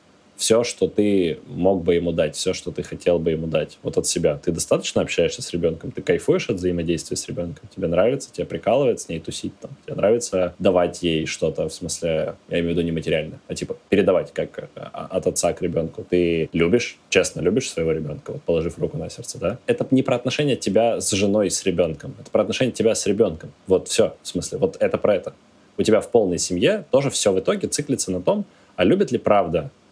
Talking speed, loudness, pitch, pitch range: 215 wpm, -22 LUFS, 90 Hz, 85-130 Hz